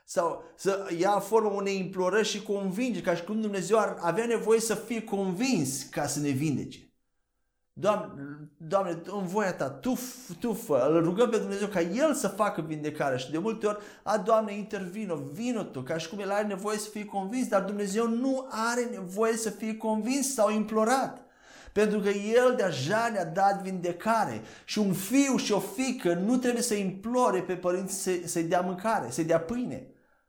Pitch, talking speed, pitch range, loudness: 205 Hz, 180 wpm, 185-225 Hz, -29 LUFS